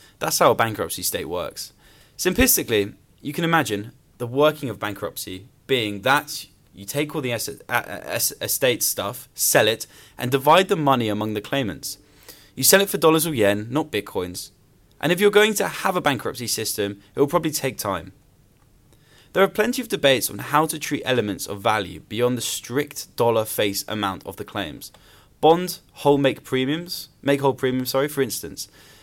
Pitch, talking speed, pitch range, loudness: 135 Hz, 175 wpm, 105-155 Hz, -22 LUFS